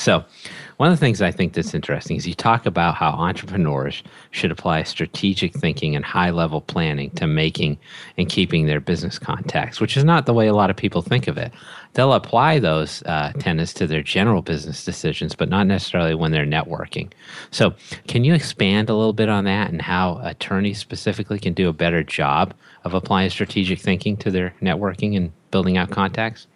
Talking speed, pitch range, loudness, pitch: 195 wpm, 85-105 Hz, -20 LUFS, 95 Hz